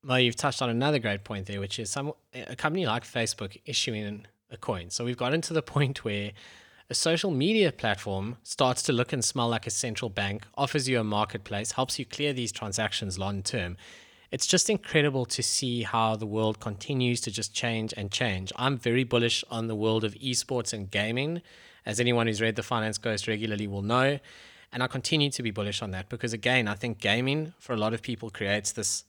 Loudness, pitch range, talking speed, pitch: -28 LUFS, 105-130 Hz, 215 wpm, 115 Hz